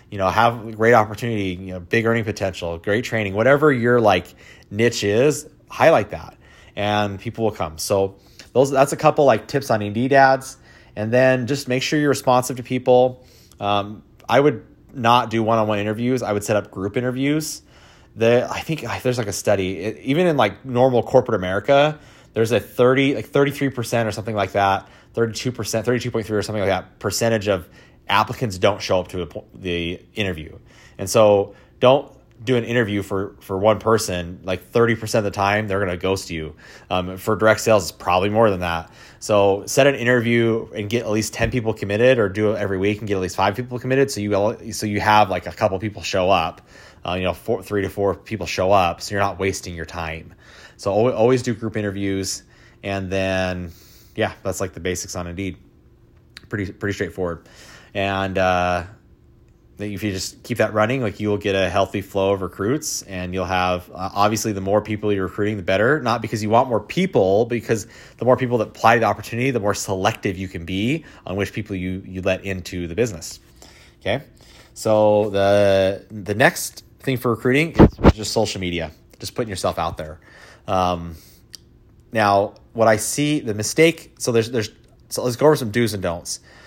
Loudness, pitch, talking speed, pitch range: -20 LUFS, 105 Hz, 195 wpm, 95-120 Hz